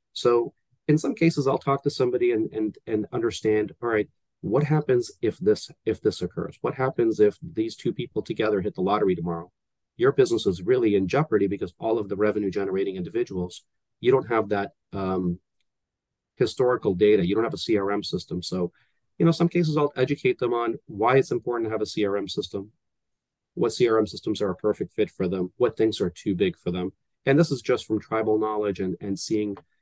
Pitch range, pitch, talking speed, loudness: 105-145 Hz, 110 Hz, 205 wpm, -25 LUFS